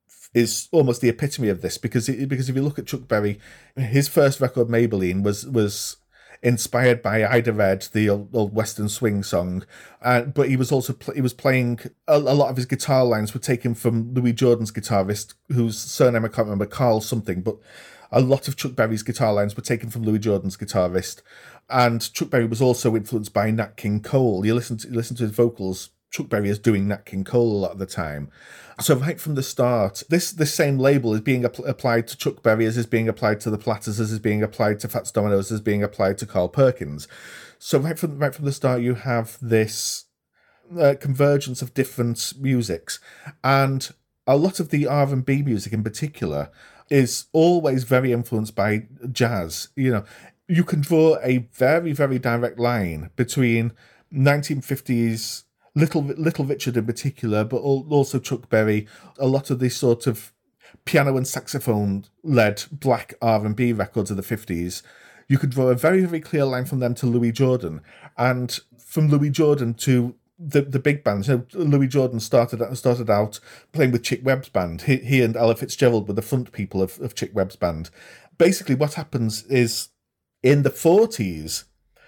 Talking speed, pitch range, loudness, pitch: 195 wpm, 110-135 Hz, -22 LUFS, 120 Hz